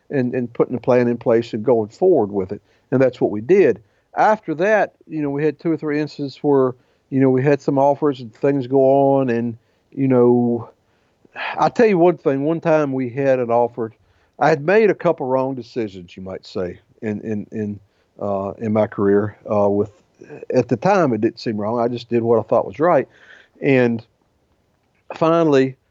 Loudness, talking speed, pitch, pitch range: -18 LUFS, 205 wpm, 125 Hz, 110-145 Hz